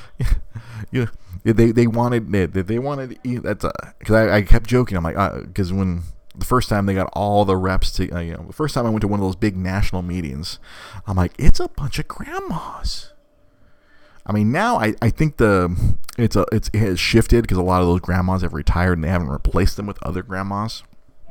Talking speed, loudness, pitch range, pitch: 215 wpm, -20 LUFS, 90-115 Hz, 100 Hz